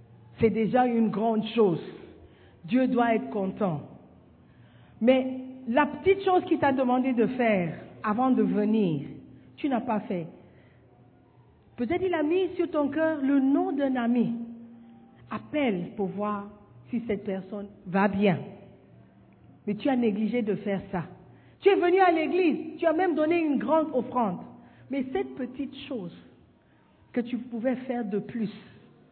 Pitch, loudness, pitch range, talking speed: 235 Hz, -27 LUFS, 205-280 Hz, 150 wpm